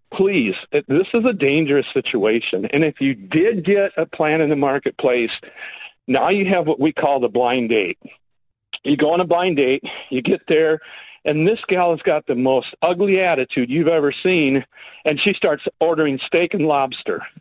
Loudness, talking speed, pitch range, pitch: -18 LUFS, 185 wpm, 135-185 Hz, 155 Hz